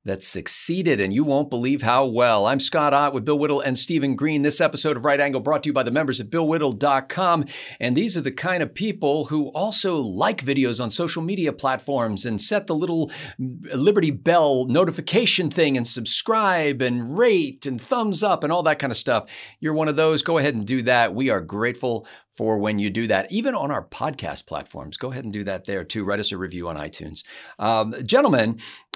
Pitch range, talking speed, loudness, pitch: 120-160 Hz, 215 wpm, -21 LUFS, 140 Hz